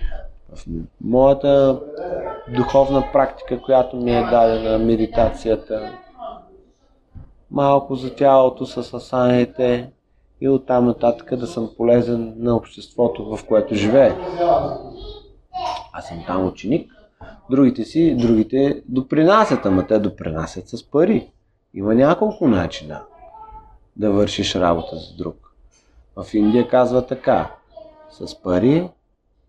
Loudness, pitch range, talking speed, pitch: -18 LUFS, 110-140 Hz, 105 wpm, 125 Hz